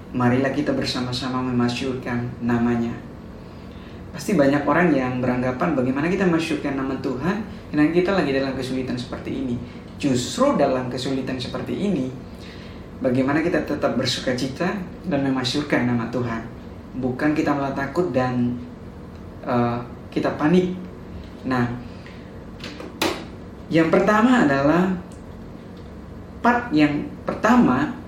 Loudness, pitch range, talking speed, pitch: -22 LUFS, 125-150 Hz, 110 wpm, 130 Hz